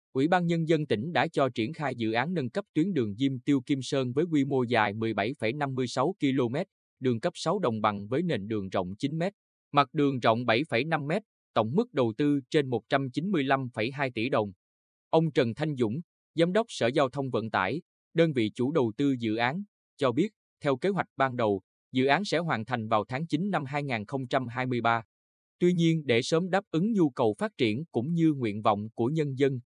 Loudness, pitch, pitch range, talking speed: -28 LUFS, 135 Hz, 115-160 Hz, 205 wpm